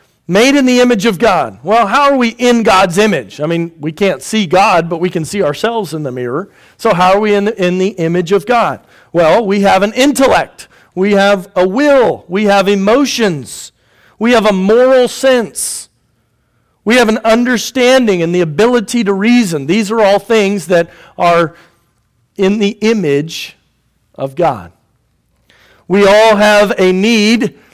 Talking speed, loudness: 175 wpm, -11 LUFS